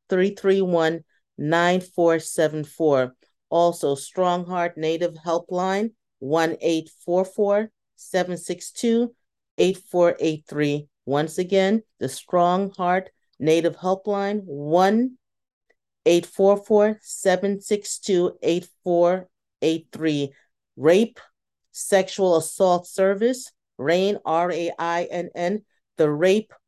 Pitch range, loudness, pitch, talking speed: 160-195 Hz, -22 LUFS, 175 Hz, 65 wpm